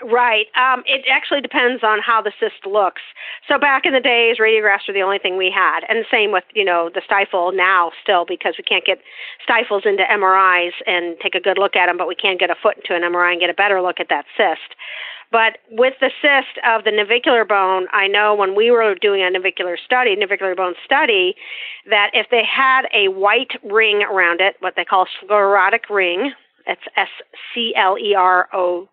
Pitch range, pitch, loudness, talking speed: 185-240 Hz, 205 Hz, -16 LUFS, 215 wpm